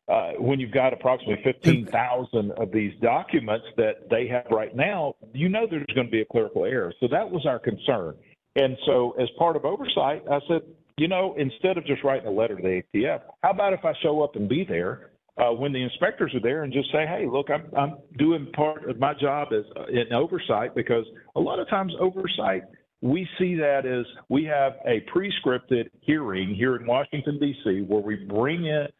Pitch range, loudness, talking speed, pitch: 120-155 Hz, -25 LUFS, 210 wpm, 140 Hz